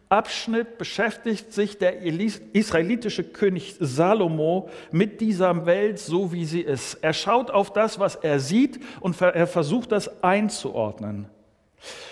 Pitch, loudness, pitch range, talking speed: 185 Hz, -24 LUFS, 165-210 Hz, 130 wpm